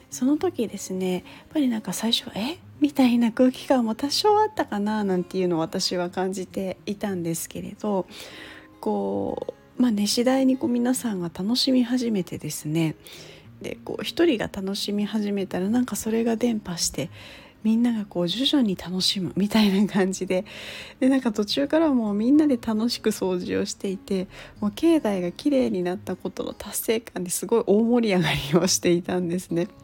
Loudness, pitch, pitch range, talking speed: -24 LUFS, 210 Hz, 185-250 Hz, 355 characters per minute